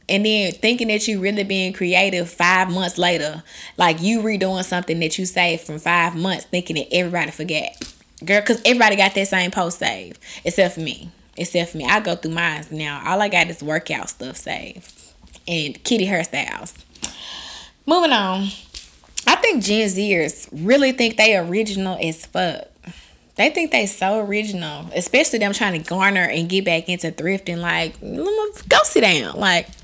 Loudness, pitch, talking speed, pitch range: -19 LUFS, 185 Hz, 175 wpm, 170-205 Hz